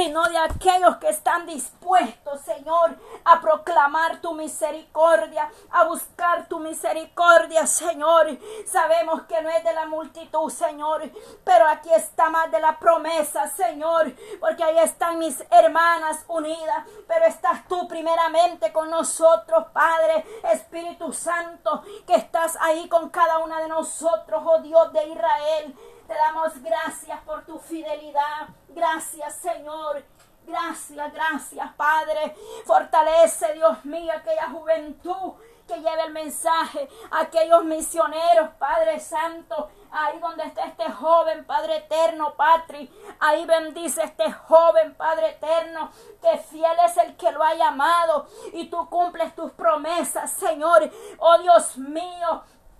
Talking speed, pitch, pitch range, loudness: 130 wpm, 325 Hz, 315-335 Hz, -21 LUFS